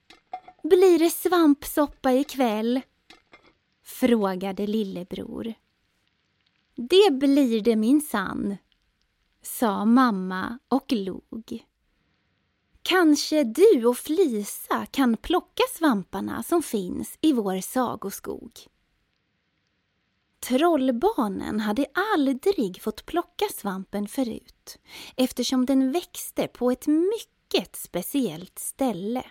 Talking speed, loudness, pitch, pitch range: 90 wpm, -24 LUFS, 255 Hz, 205-305 Hz